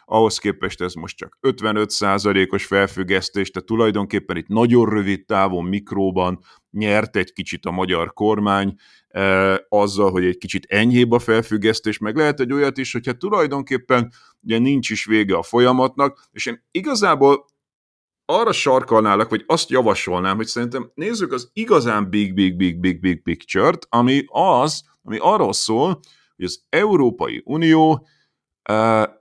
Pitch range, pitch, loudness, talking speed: 95-120 Hz, 110 Hz, -19 LUFS, 150 wpm